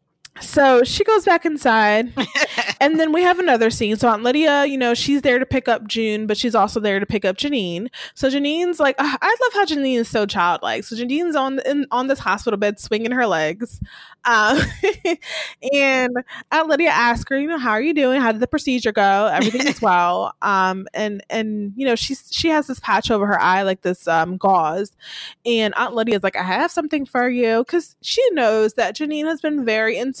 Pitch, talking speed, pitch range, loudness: 245 Hz, 215 wpm, 215-285 Hz, -18 LUFS